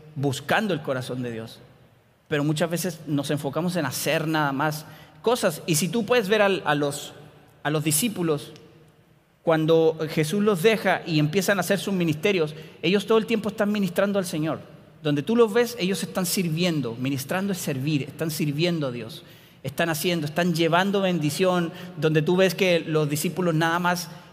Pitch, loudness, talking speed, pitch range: 165 Hz, -24 LUFS, 175 wpm, 150-185 Hz